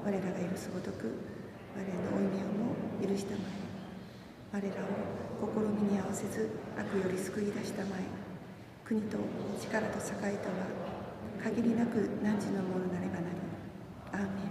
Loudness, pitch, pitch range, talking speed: -36 LUFS, 200 Hz, 195-210 Hz, 270 characters per minute